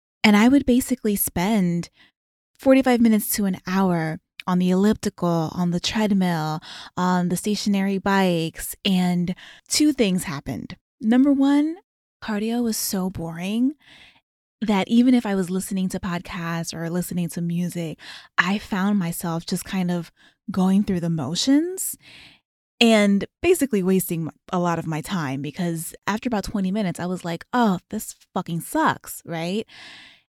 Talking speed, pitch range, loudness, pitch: 145 wpm, 175-220 Hz, -22 LUFS, 190 Hz